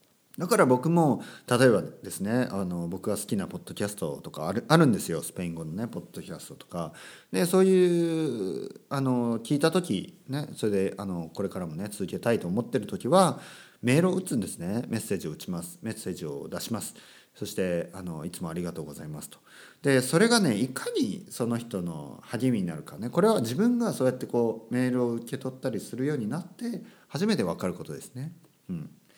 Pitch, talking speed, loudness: 130 Hz, 405 characters per minute, -28 LUFS